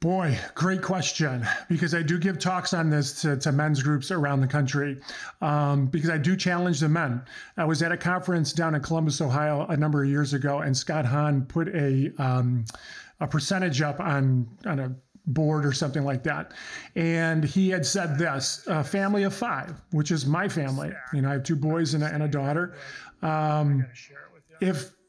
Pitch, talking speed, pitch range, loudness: 155 Hz, 195 wpm, 140-170 Hz, -26 LUFS